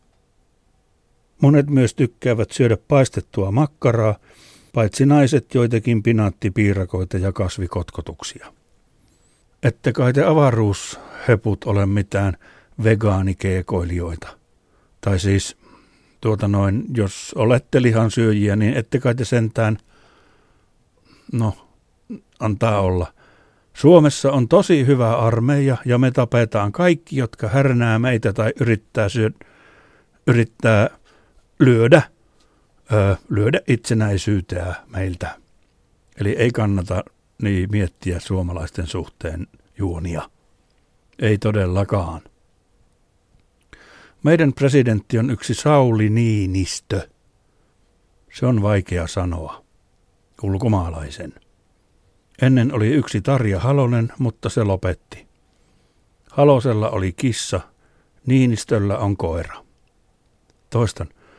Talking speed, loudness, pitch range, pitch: 90 wpm, -19 LUFS, 95-120 Hz, 110 Hz